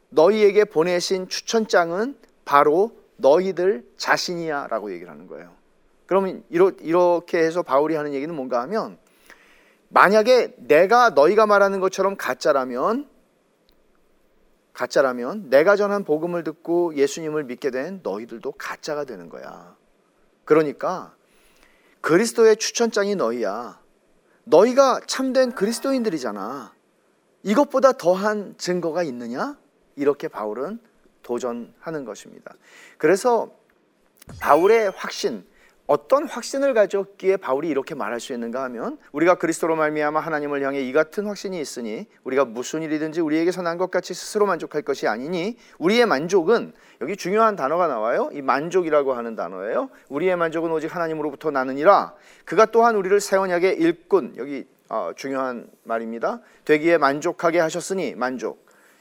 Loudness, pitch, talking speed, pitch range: -21 LUFS, 185 Hz, 335 characters per minute, 155-225 Hz